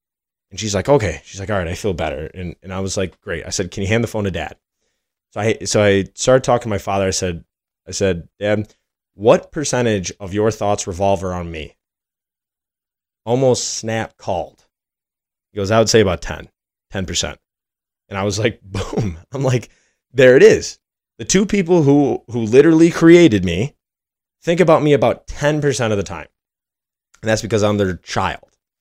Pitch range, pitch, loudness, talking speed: 95-125 Hz, 105 Hz, -17 LUFS, 190 wpm